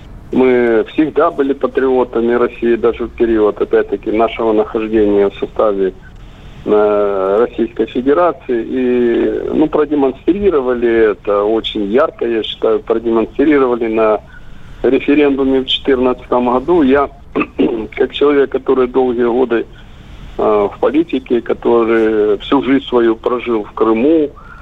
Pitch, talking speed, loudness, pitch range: 120 Hz, 110 wpm, -14 LUFS, 110-135 Hz